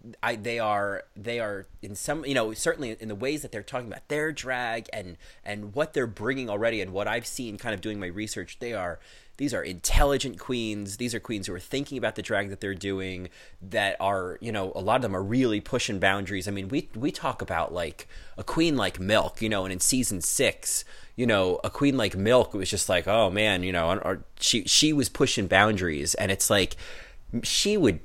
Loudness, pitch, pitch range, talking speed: -27 LUFS, 110 Hz, 100-125 Hz, 225 wpm